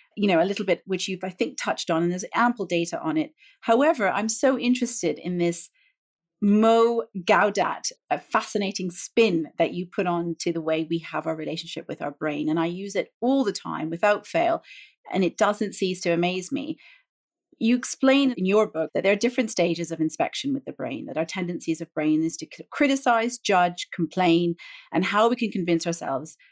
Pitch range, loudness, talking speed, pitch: 170-235 Hz, -24 LUFS, 200 wpm, 190 Hz